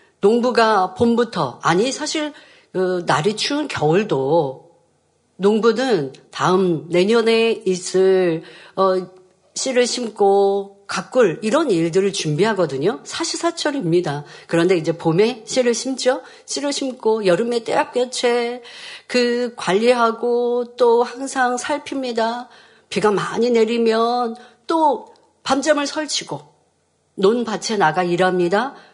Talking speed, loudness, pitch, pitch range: 230 characters per minute, -19 LUFS, 230 Hz, 190-255 Hz